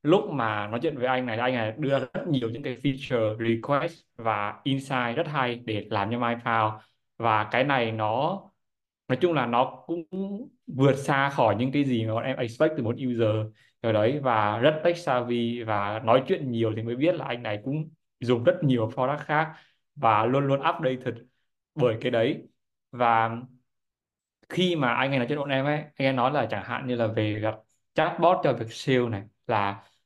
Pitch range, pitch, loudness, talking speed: 115-140 Hz, 125 Hz, -26 LUFS, 205 wpm